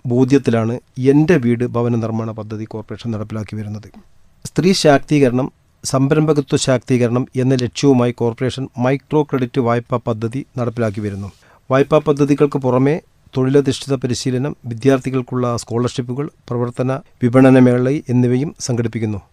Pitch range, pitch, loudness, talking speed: 115-135 Hz, 125 Hz, -17 LUFS, 100 wpm